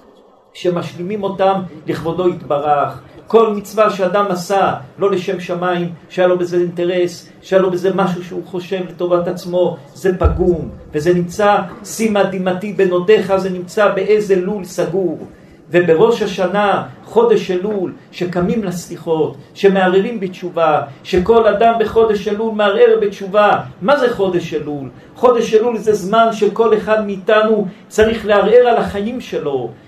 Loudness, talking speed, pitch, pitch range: -15 LUFS, 130 wpm, 190 Hz, 175-210 Hz